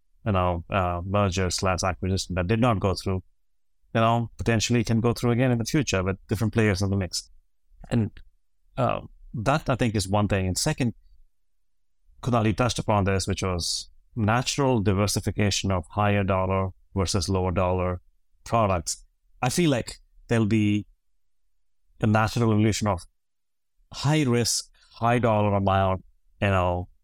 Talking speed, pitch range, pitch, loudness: 150 wpm, 90-115 Hz, 100 Hz, -25 LUFS